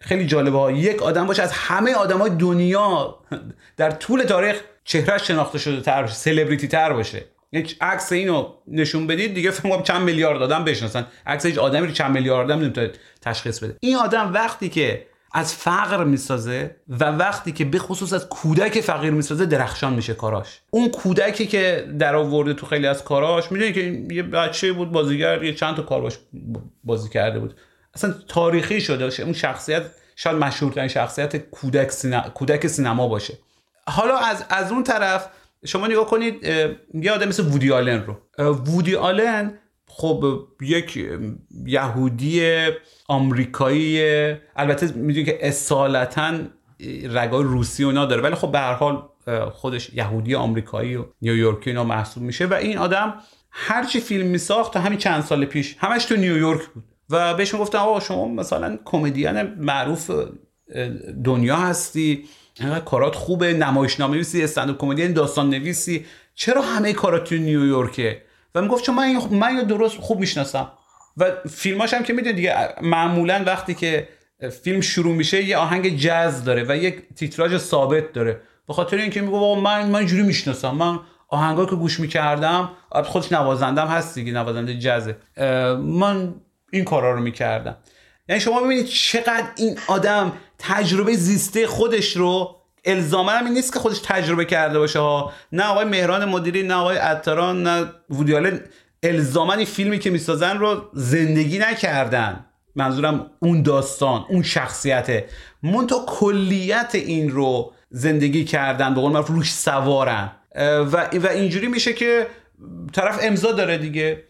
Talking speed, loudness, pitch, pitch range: 150 wpm, -20 LUFS, 160 Hz, 140-195 Hz